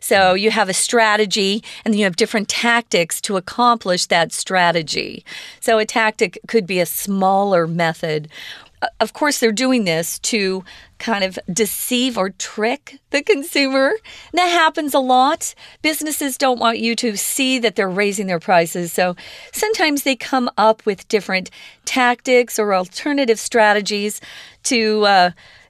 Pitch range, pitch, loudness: 190-255 Hz, 220 Hz, -17 LUFS